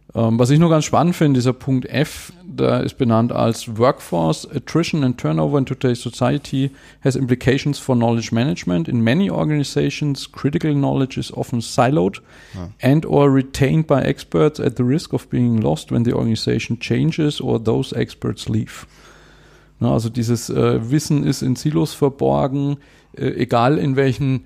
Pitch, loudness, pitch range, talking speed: 135 Hz, -19 LUFS, 120-145 Hz, 155 wpm